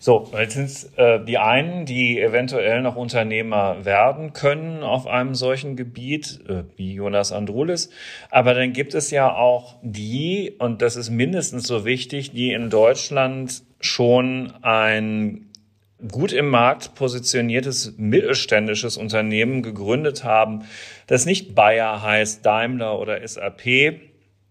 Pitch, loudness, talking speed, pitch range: 125 Hz, -20 LUFS, 130 wpm, 110-130 Hz